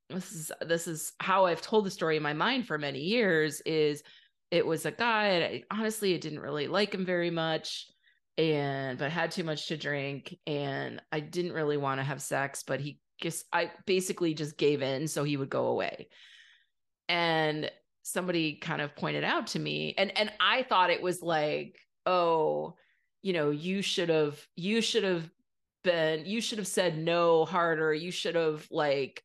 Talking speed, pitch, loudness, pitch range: 190 wpm, 165 Hz, -30 LUFS, 150-185 Hz